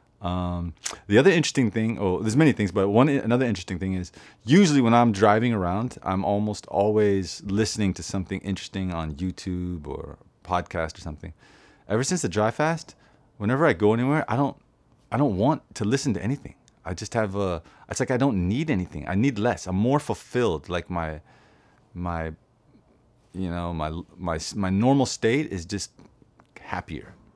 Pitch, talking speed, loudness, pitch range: 100 Hz, 175 wpm, -25 LUFS, 90-120 Hz